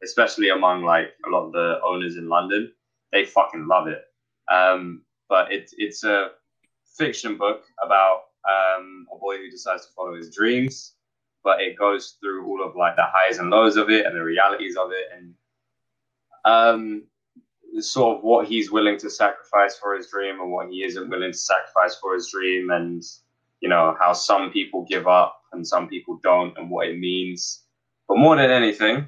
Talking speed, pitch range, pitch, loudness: 190 wpm, 90-120 Hz, 100 Hz, -21 LUFS